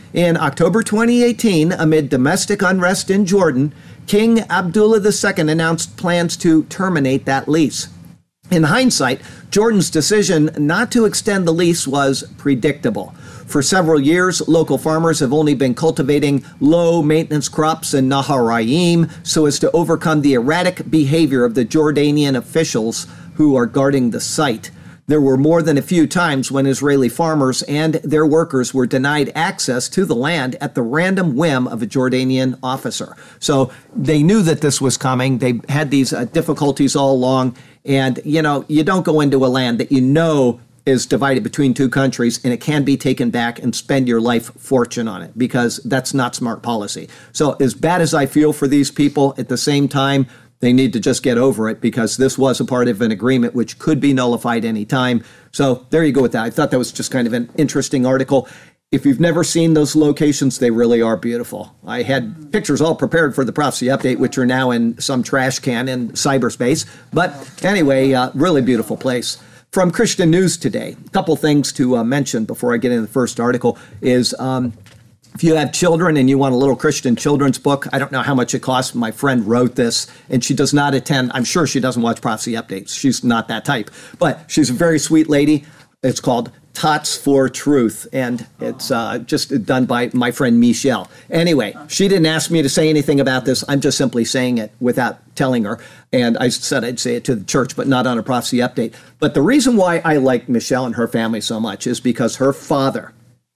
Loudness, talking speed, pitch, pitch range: -16 LUFS, 200 wpm, 140 Hz, 125-160 Hz